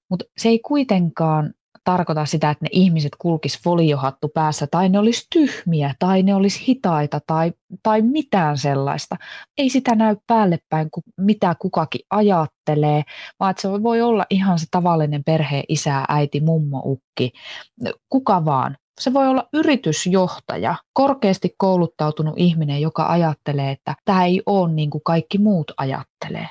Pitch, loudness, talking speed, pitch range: 175 Hz, -19 LUFS, 145 wpm, 155-205 Hz